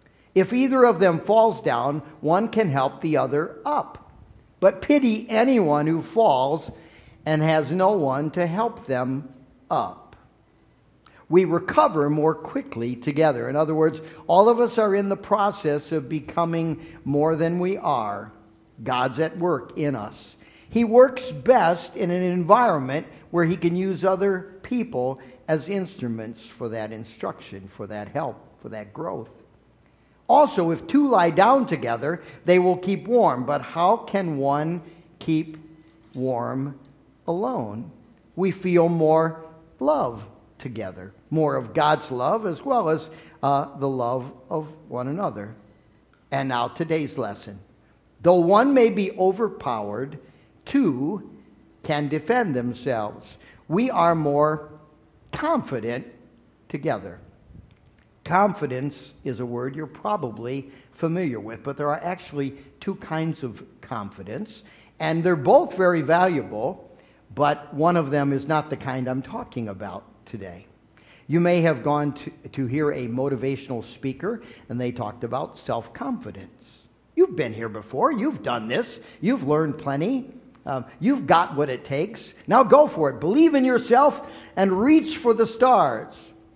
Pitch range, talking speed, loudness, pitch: 125-185 Hz, 140 wpm, -23 LUFS, 155 Hz